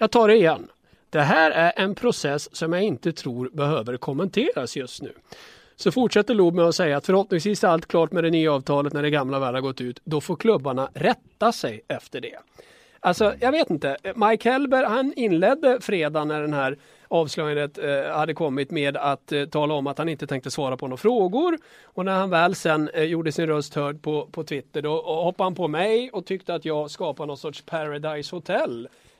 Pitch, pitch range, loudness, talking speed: 160 Hz, 145-190 Hz, -23 LUFS, 205 wpm